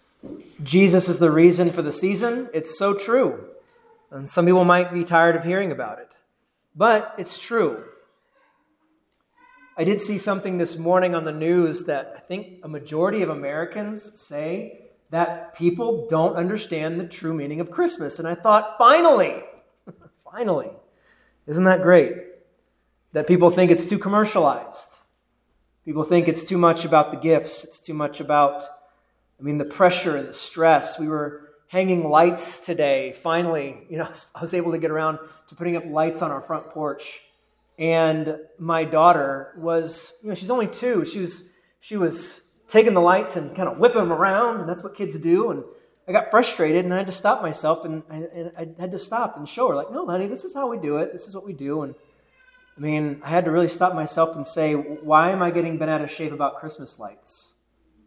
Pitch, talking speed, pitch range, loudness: 170 Hz, 195 wpm, 155-195 Hz, -21 LUFS